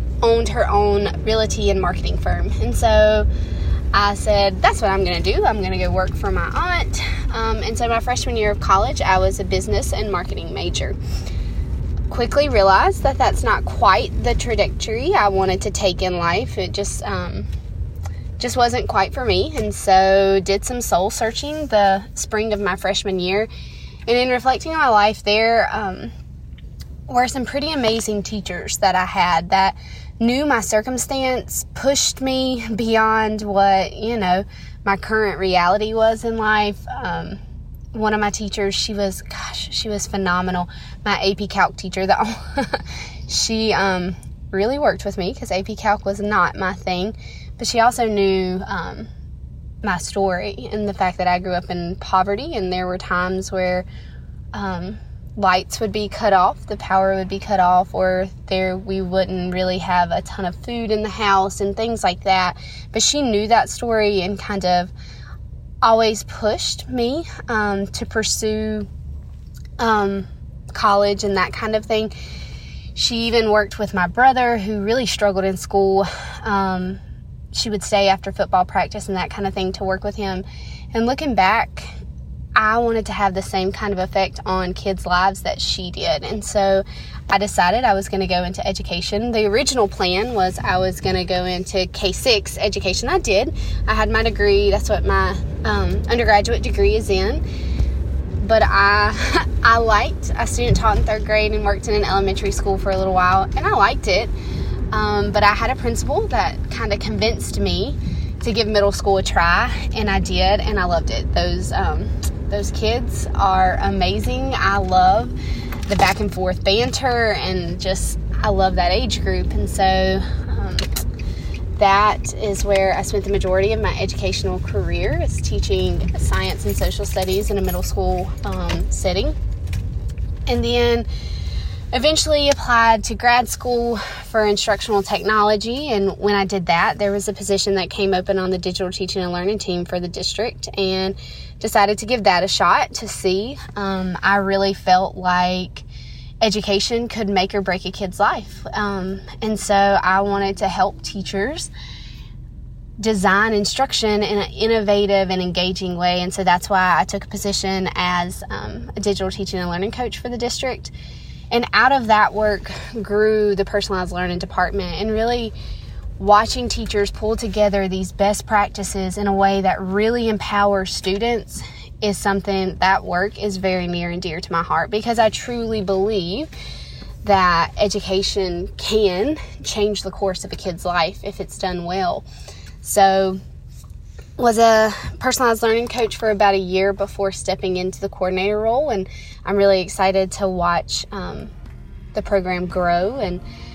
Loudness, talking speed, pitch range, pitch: -19 LUFS, 170 wpm, 180-210 Hz, 195 Hz